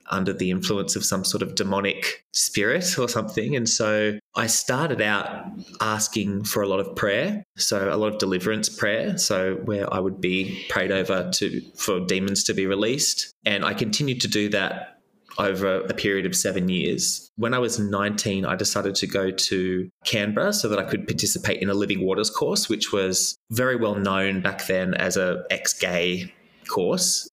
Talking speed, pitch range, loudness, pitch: 185 wpm, 95-110 Hz, -23 LUFS, 100 Hz